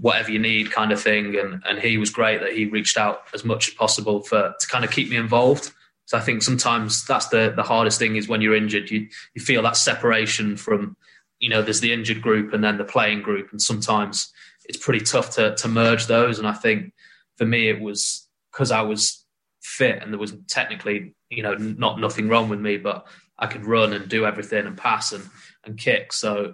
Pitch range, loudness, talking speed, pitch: 105-115 Hz, -21 LUFS, 225 wpm, 110 Hz